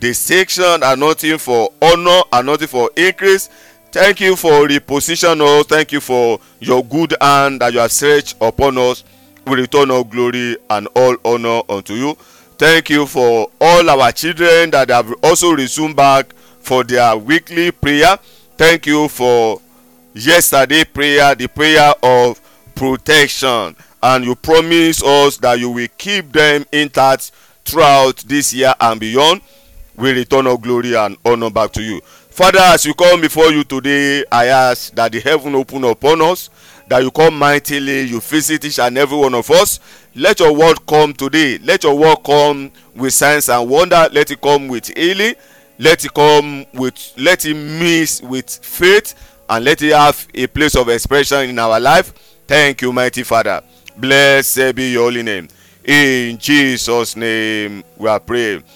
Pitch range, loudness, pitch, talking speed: 120-155 Hz, -12 LUFS, 140 Hz, 165 wpm